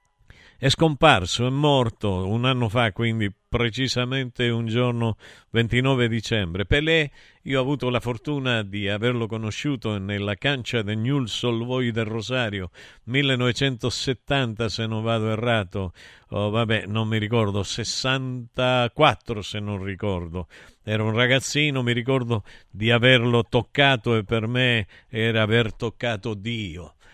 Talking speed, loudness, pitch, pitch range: 130 wpm, -23 LUFS, 115 Hz, 110-125 Hz